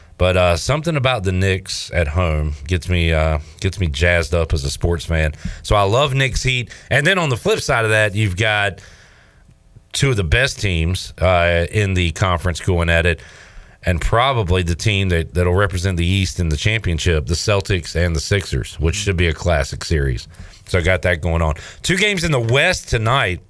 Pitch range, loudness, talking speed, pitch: 85-105 Hz, -18 LUFS, 205 wpm, 90 Hz